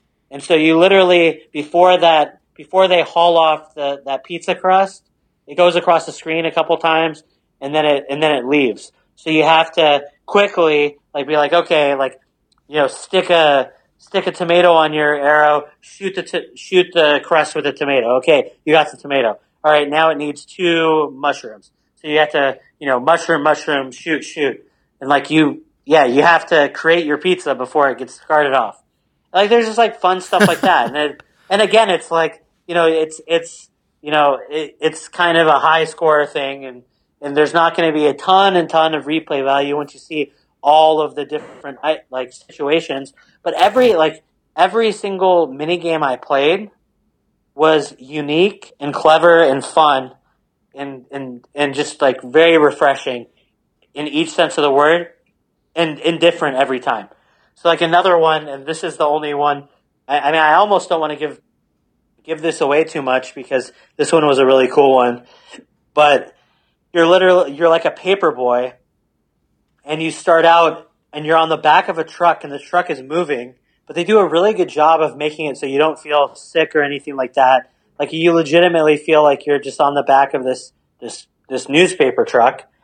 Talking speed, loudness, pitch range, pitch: 195 wpm, -15 LUFS, 145-170 Hz, 155 Hz